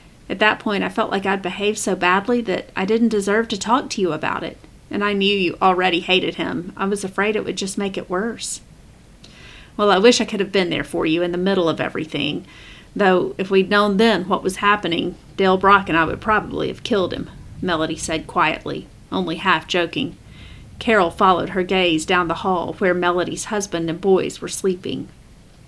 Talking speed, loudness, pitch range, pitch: 205 wpm, -19 LUFS, 175-205 Hz, 190 Hz